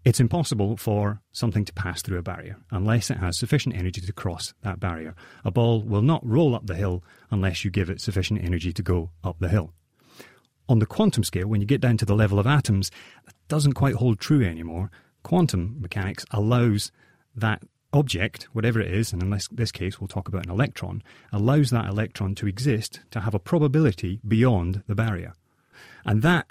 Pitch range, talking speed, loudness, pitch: 95-120 Hz, 195 wpm, -25 LUFS, 105 Hz